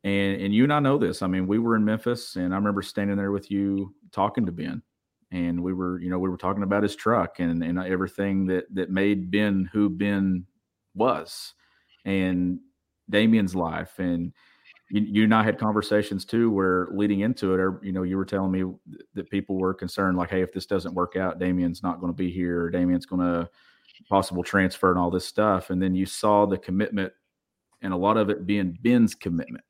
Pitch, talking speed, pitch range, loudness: 95 Hz, 215 wpm, 90-100 Hz, -25 LUFS